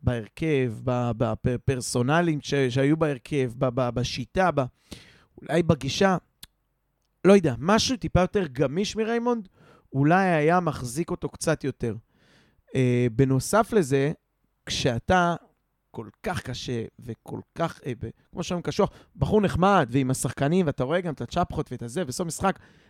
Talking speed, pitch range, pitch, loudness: 120 wpm, 130-180 Hz, 145 Hz, -25 LUFS